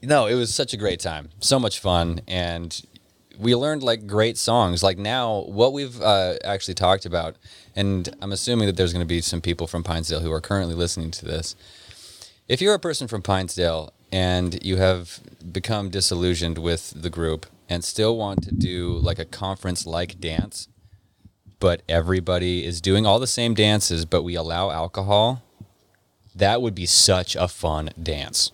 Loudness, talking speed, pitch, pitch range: -22 LUFS, 175 wpm, 95 Hz, 85-105 Hz